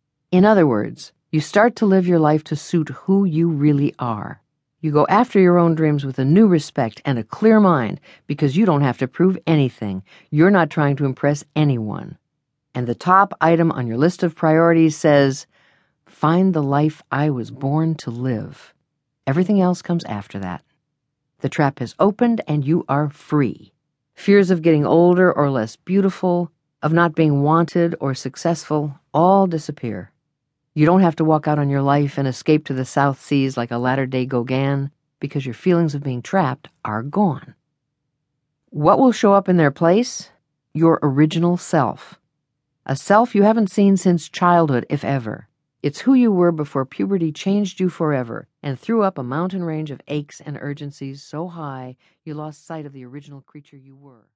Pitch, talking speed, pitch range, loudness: 150 Hz, 180 wpm, 140-175 Hz, -18 LUFS